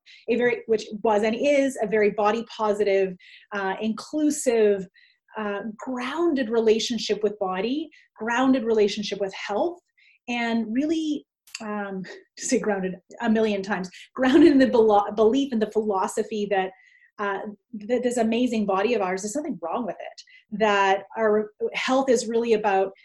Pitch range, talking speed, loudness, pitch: 205-260 Hz, 145 wpm, -24 LUFS, 220 Hz